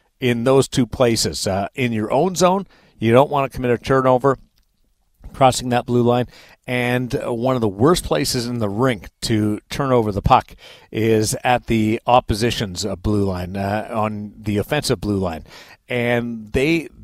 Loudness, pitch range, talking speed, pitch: -19 LUFS, 105-130 Hz, 170 wpm, 120 Hz